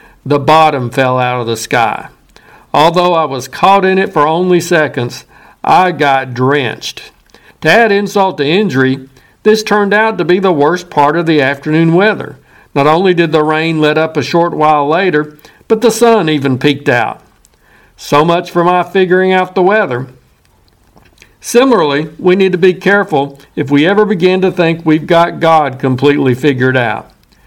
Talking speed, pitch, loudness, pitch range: 175 wpm, 155 Hz, -11 LUFS, 140-185 Hz